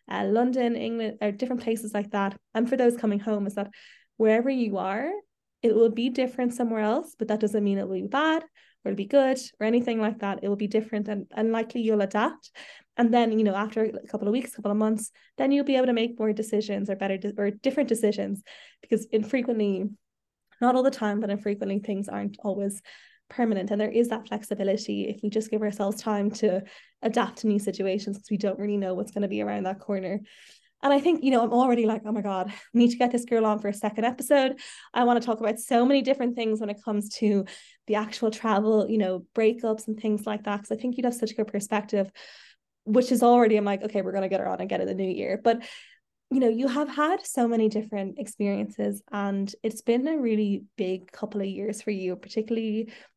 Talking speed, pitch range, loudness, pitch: 235 wpm, 205-240 Hz, -26 LUFS, 215 Hz